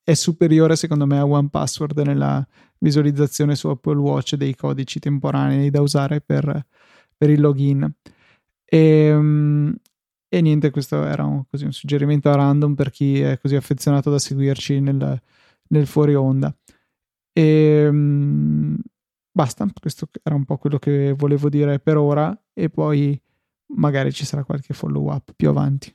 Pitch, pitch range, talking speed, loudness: 145 Hz, 140-150 Hz, 150 wpm, -19 LUFS